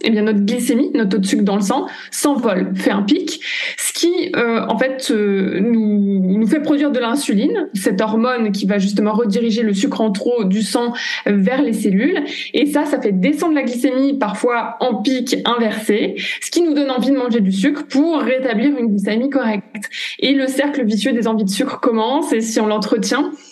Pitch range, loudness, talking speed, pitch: 215-280 Hz, -17 LUFS, 205 wpm, 240 Hz